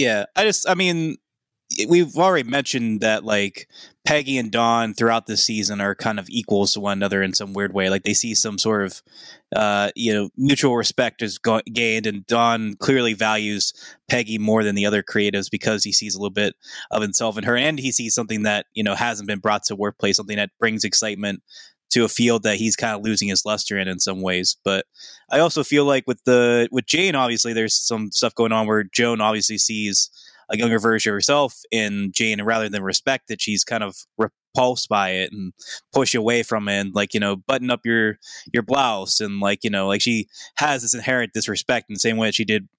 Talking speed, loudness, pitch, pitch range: 225 wpm, -20 LUFS, 110 Hz, 105-120 Hz